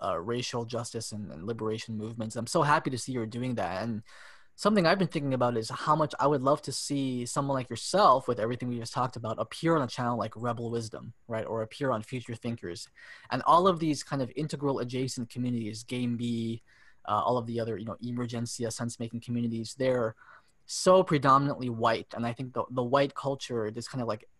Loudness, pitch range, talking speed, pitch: -30 LUFS, 115-135 Hz, 215 wpm, 120 Hz